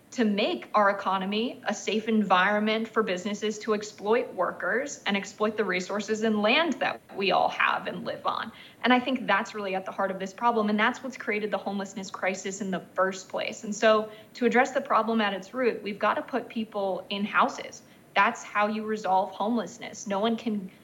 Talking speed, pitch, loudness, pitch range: 205 wpm, 210 Hz, -27 LUFS, 200-225 Hz